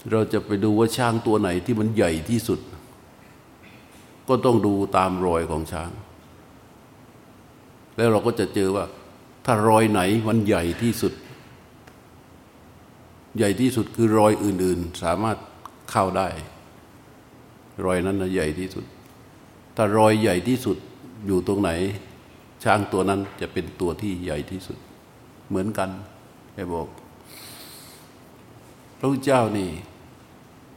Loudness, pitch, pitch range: -23 LUFS, 100 Hz, 95-115 Hz